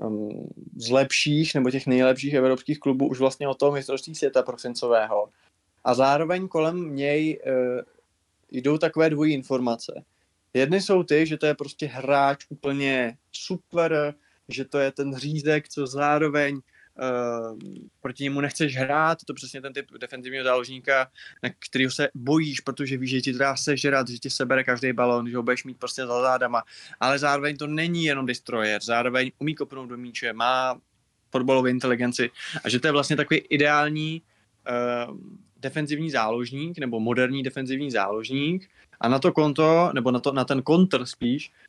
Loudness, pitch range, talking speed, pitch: -24 LUFS, 125-150 Hz, 160 wpm, 135 Hz